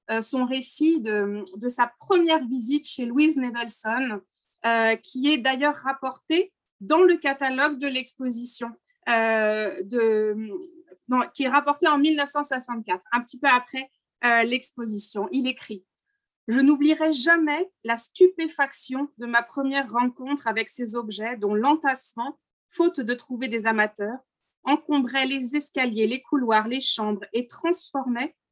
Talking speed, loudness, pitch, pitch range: 135 wpm, -24 LUFS, 260 Hz, 230-290 Hz